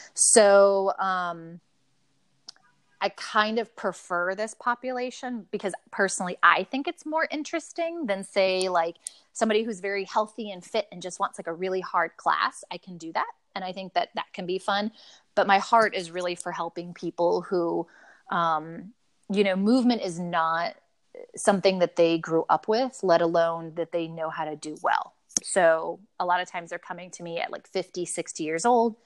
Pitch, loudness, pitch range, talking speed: 185 Hz, -26 LUFS, 175-215 Hz, 185 wpm